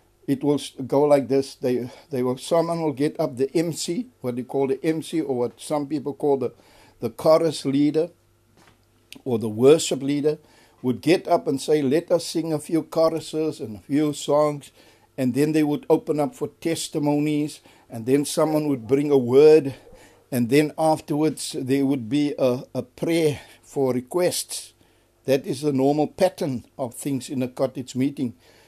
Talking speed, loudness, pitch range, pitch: 180 wpm, -23 LUFS, 130-155 Hz, 145 Hz